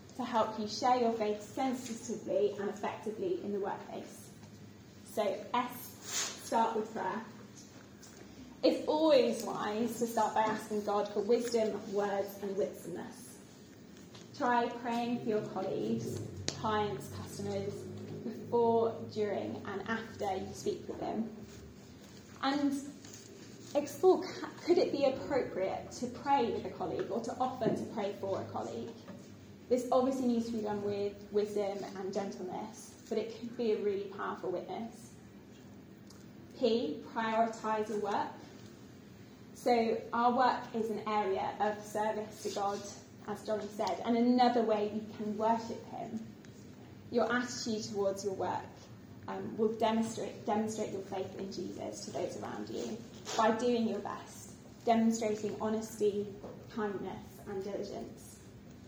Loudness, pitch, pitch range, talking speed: -35 LUFS, 220 Hz, 205-235 Hz, 135 wpm